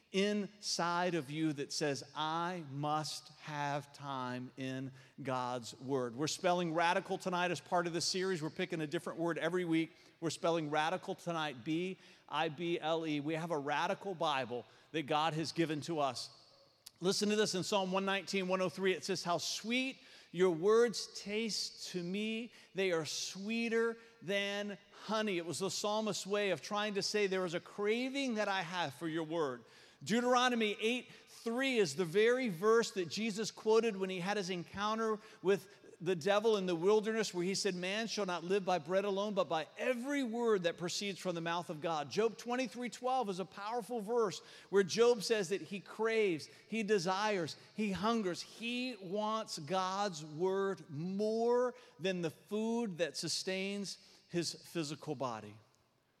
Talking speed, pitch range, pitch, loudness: 165 wpm, 165-210 Hz, 185 Hz, -36 LUFS